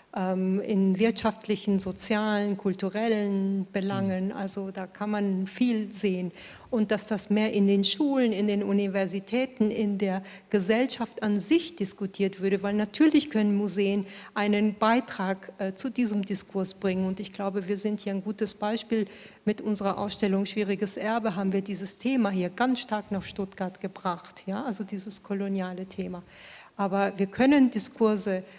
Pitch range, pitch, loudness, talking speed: 195-215 Hz, 200 Hz, -28 LUFS, 150 wpm